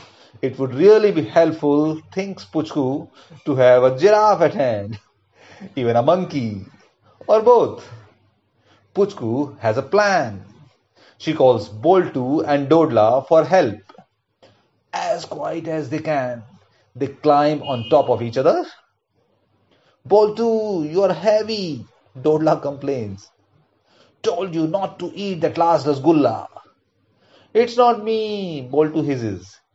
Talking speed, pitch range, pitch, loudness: 120 wpm, 125-185 Hz, 155 Hz, -18 LUFS